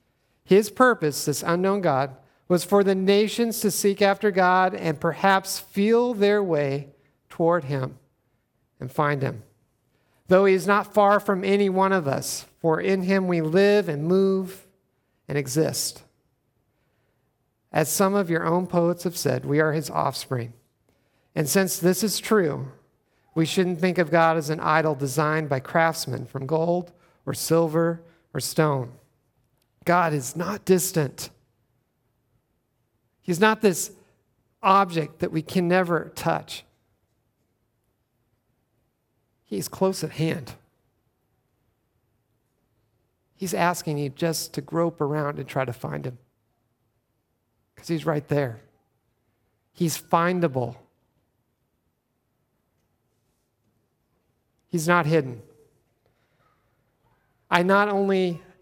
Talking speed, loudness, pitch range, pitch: 120 wpm, -23 LUFS, 125-180 Hz, 150 Hz